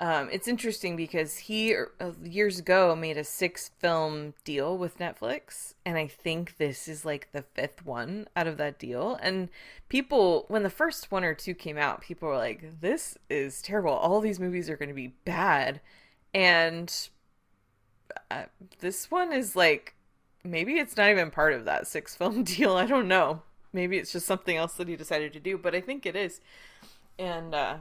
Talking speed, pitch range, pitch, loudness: 190 wpm, 160-195 Hz, 175 Hz, -29 LUFS